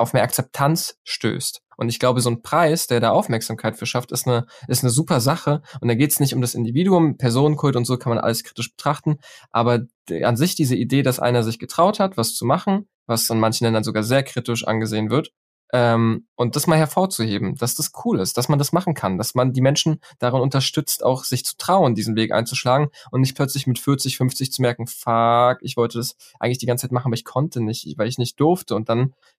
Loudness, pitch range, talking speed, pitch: -20 LUFS, 115-140 Hz, 235 wpm, 125 Hz